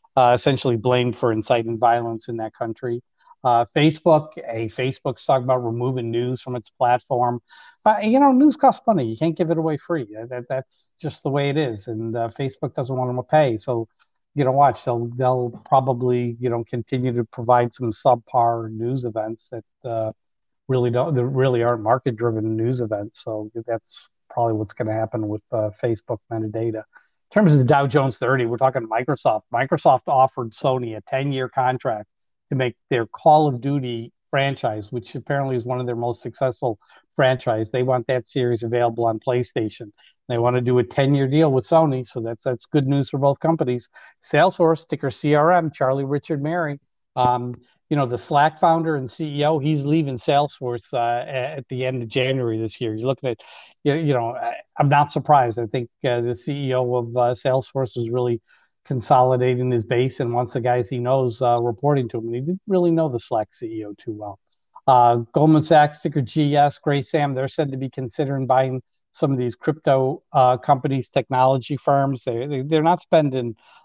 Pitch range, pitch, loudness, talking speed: 120-145 Hz, 130 Hz, -21 LUFS, 190 wpm